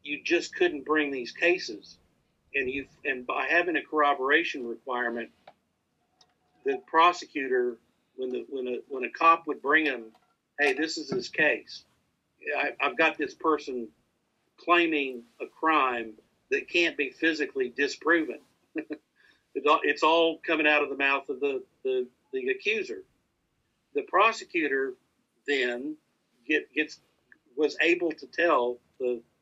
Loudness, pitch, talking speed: -27 LUFS, 160 Hz, 135 wpm